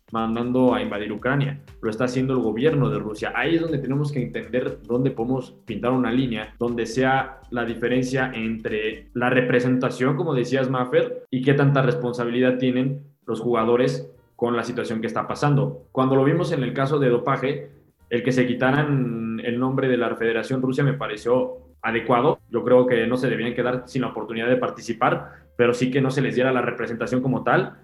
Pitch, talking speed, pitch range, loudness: 125 Hz, 190 wpm, 115-130 Hz, -23 LUFS